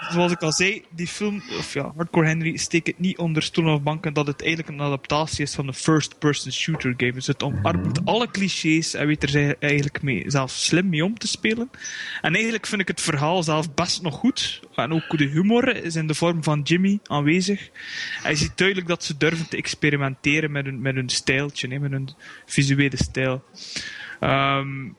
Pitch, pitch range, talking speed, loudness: 160 Hz, 145-180 Hz, 195 wpm, -23 LUFS